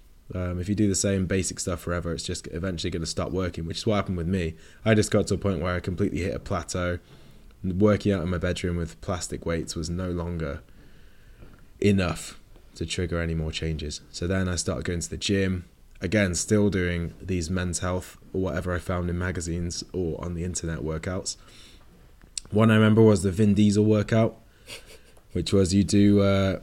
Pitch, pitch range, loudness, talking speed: 90 Hz, 85-100 Hz, -26 LUFS, 200 wpm